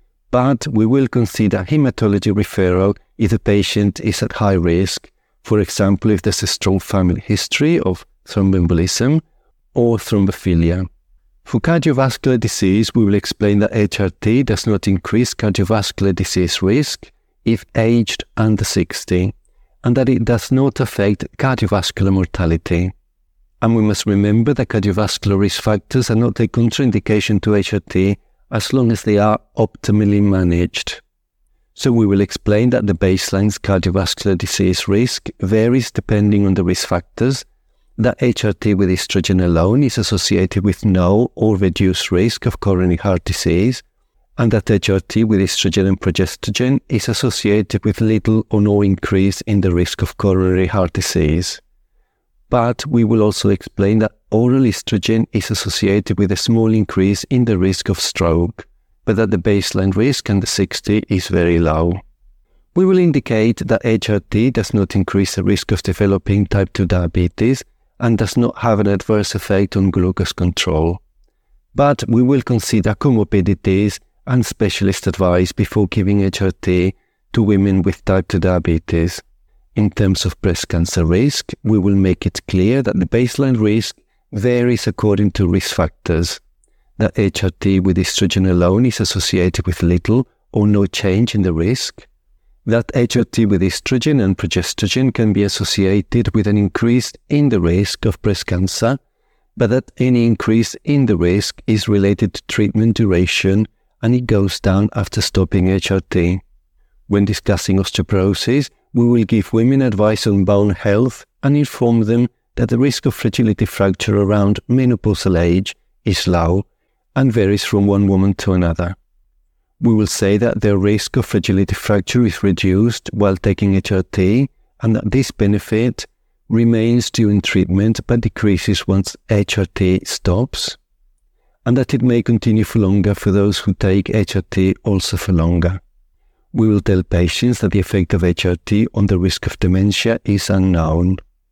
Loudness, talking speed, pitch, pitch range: -16 LUFS, 150 wpm, 100 Hz, 95-115 Hz